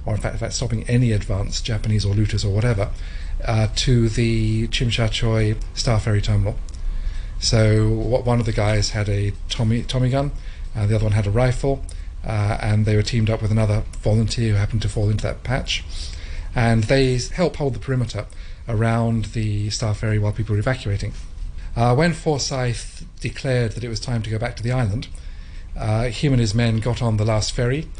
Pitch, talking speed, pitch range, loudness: 110 Hz, 200 wpm, 100-120 Hz, -21 LUFS